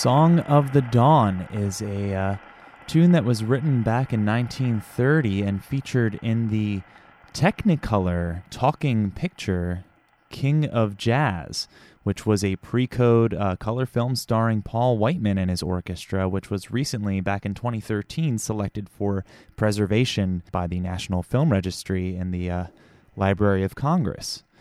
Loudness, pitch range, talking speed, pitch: -23 LUFS, 95-125 Hz, 140 wpm, 105 Hz